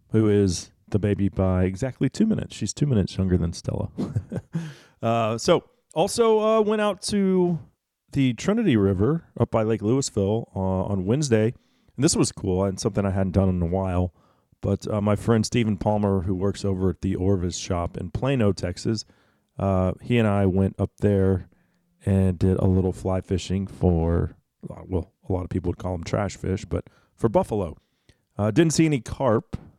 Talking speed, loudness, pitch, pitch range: 185 wpm, -24 LUFS, 100 Hz, 95-120 Hz